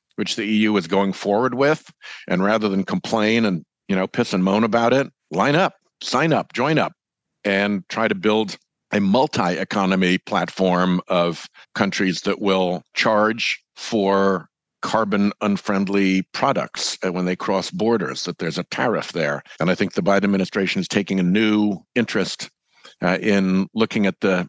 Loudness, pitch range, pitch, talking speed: -20 LUFS, 95-110 Hz, 100 Hz, 160 wpm